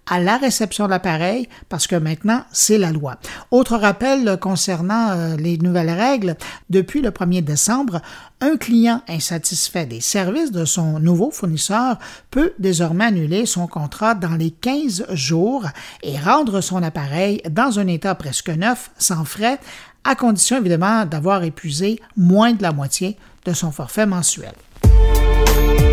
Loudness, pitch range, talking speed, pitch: -18 LUFS, 165-225 Hz, 145 wpm, 185 Hz